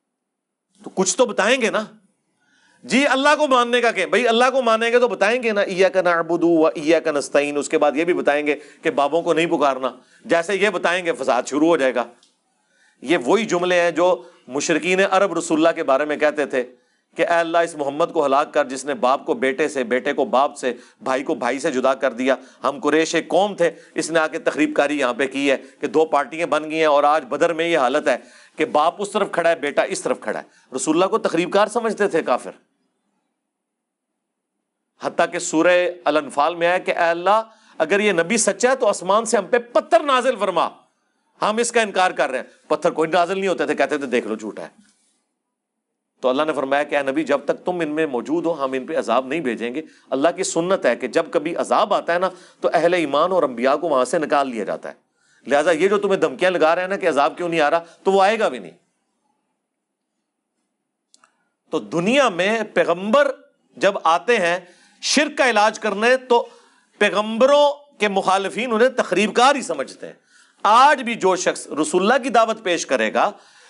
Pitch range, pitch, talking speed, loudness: 150-210 Hz, 170 Hz, 215 wpm, -19 LUFS